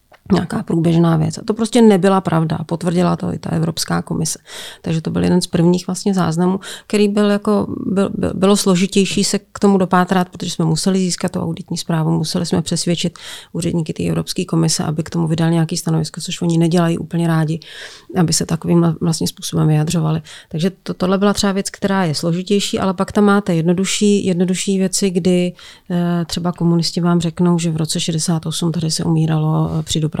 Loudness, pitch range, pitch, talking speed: -17 LUFS, 165-190 Hz, 175 Hz, 185 wpm